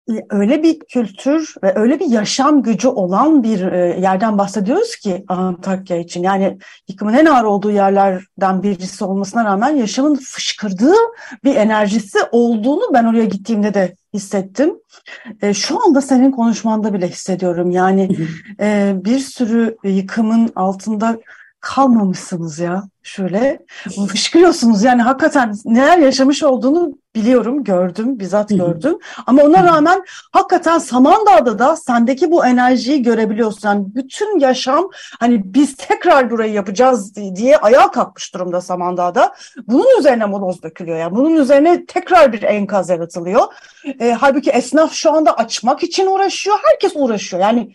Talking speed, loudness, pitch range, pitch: 135 wpm, -14 LUFS, 200-285 Hz, 235 Hz